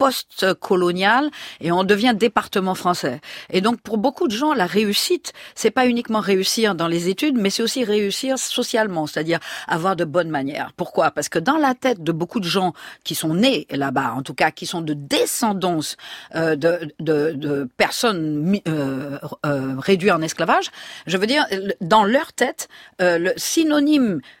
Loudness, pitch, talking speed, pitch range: -20 LUFS, 190 Hz, 165 wpm, 165-240 Hz